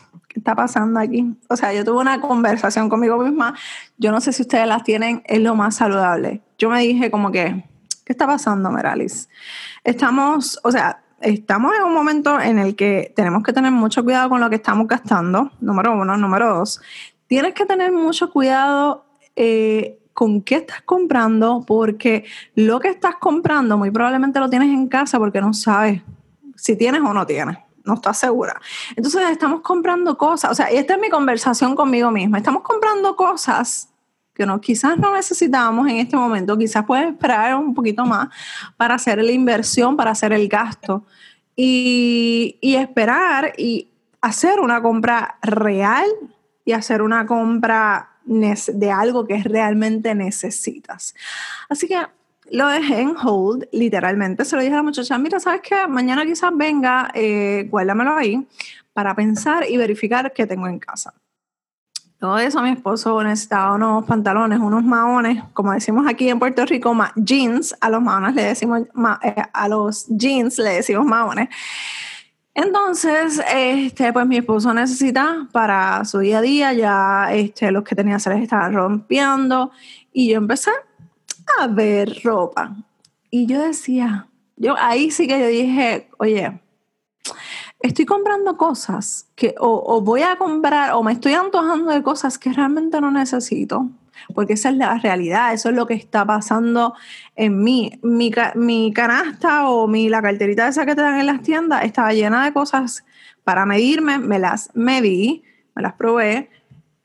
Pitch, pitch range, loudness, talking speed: 235 Hz, 215-275 Hz, -17 LUFS, 165 wpm